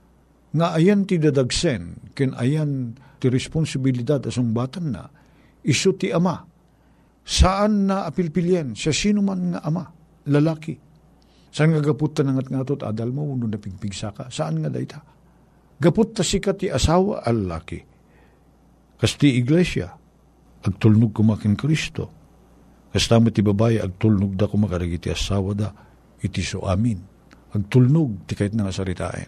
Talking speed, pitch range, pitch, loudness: 130 wpm, 110-160 Hz, 135 Hz, -22 LUFS